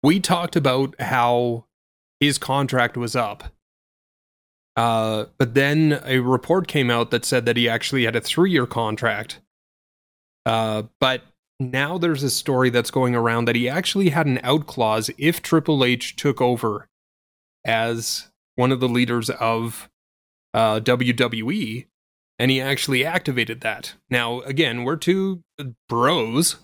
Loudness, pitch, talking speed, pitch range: -21 LUFS, 125 Hz, 145 wpm, 115-140 Hz